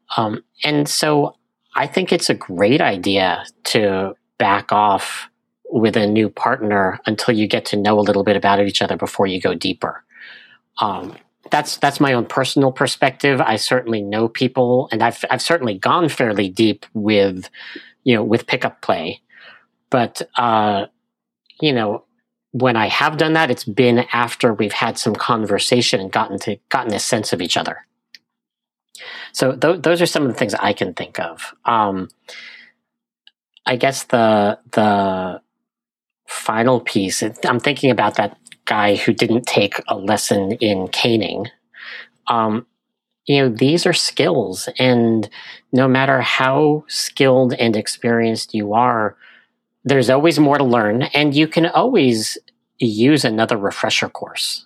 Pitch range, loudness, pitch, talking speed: 105-135 Hz, -17 LUFS, 120 Hz, 155 wpm